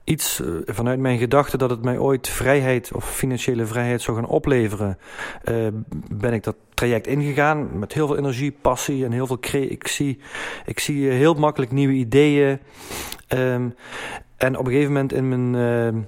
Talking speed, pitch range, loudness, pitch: 170 wpm, 120-140 Hz, -21 LUFS, 130 Hz